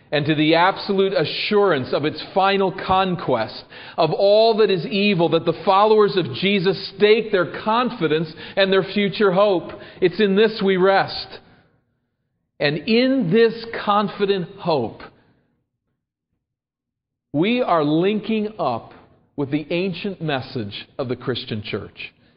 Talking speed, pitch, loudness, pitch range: 130 wpm, 190 Hz, -19 LUFS, 155-205 Hz